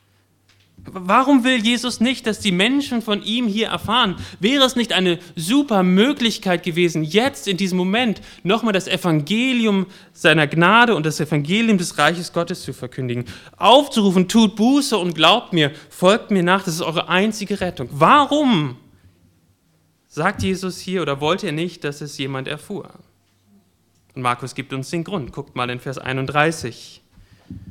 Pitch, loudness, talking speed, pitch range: 175 Hz, -18 LUFS, 155 wpm, 135-210 Hz